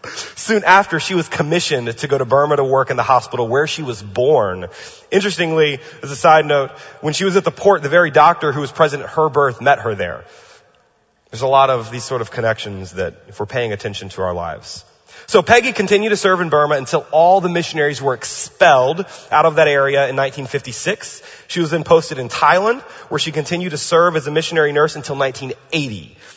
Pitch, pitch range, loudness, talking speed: 150 Hz, 135-170 Hz, -16 LUFS, 210 wpm